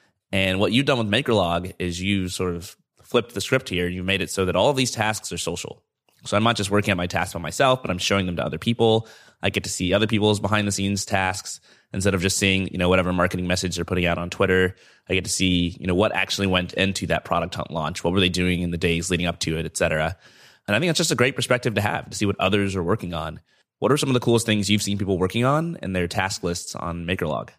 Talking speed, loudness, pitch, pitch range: 275 wpm, -22 LUFS, 95 Hz, 90-105 Hz